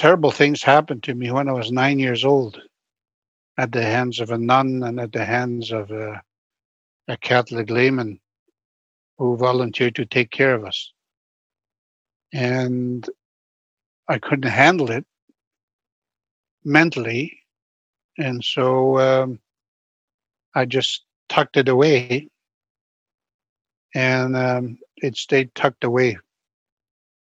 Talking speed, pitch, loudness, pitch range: 115 wpm, 125 Hz, -20 LUFS, 110-130 Hz